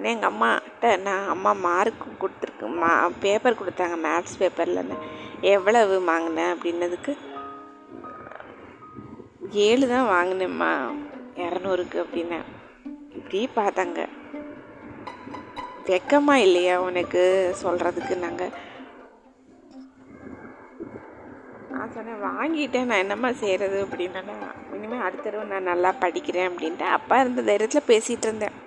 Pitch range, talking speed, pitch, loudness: 175-255 Hz, 95 wpm, 195 Hz, -24 LUFS